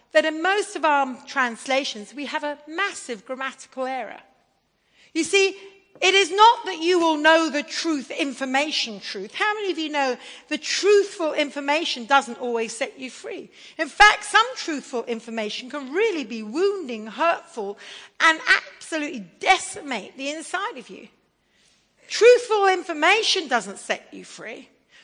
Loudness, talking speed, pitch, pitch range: -22 LUFS, 145 wpm, 310 Hz, 265-380 Hz